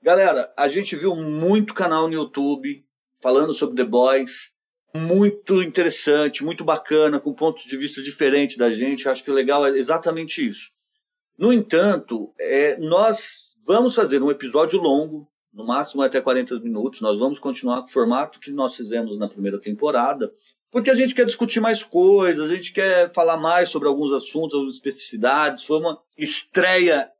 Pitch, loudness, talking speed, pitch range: 155 Hz, -20 LUFS, 170 wpm, 135-190 Hz